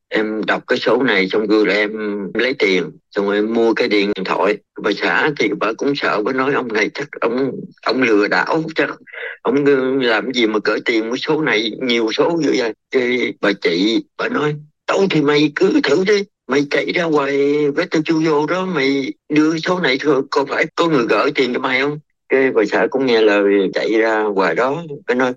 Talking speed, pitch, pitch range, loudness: 215 wpm, 140 Hz, 110-155 Hz, -17 LUFS